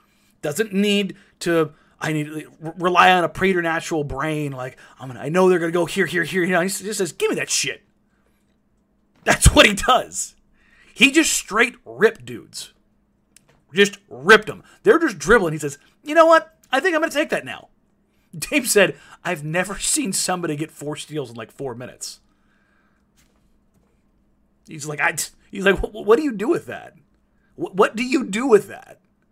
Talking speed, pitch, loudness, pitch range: 185 wpm, 190 Hz, -19 LUFS, 160-240 Hz